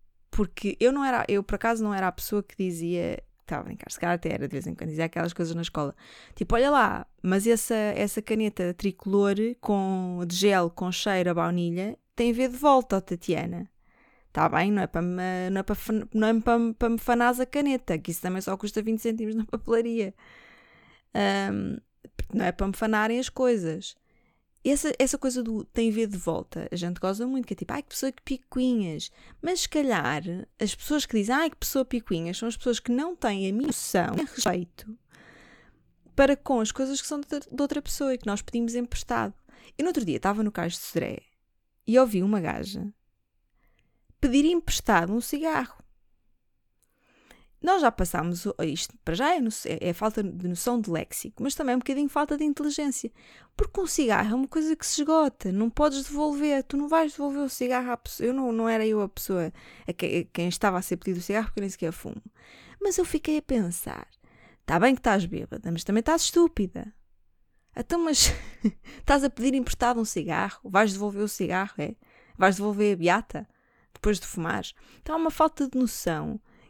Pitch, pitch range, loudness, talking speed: 225 Hz, 190-265 Hz, -27 LUFS, 205 wpm